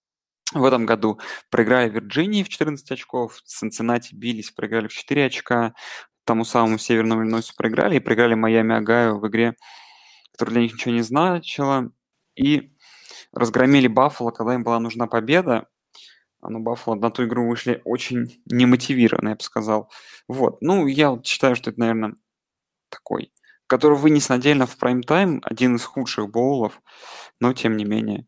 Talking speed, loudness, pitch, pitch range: 160 wpm, -21 LUFS, 120 Hz, 115-130 Hz